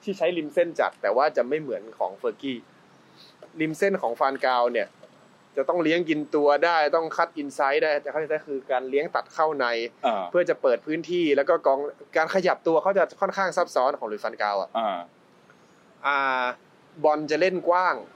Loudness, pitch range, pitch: -25 LUFS, 140-175 Hz, 155 Hz